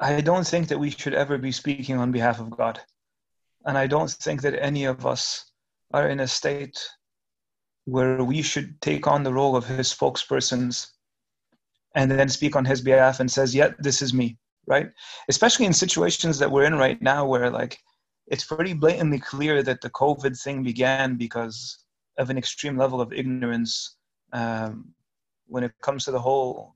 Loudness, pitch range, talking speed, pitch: -23 LUFS, 125-145 Hz, 180 wpm, 135 Hz